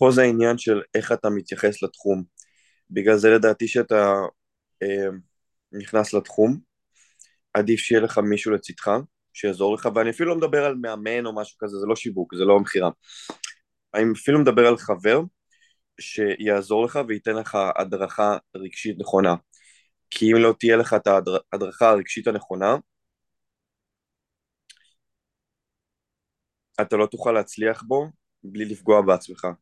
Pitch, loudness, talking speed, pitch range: 110 Hz, -22 LUFS, 135 wpm, 100-115 Hz